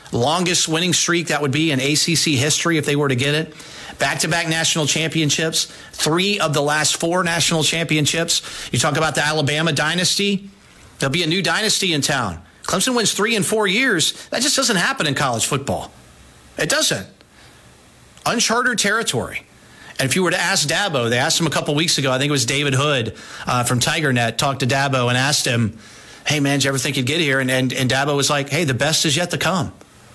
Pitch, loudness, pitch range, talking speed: 150 Hz, -18 LUFS, 135-170 Hz, 215 wpm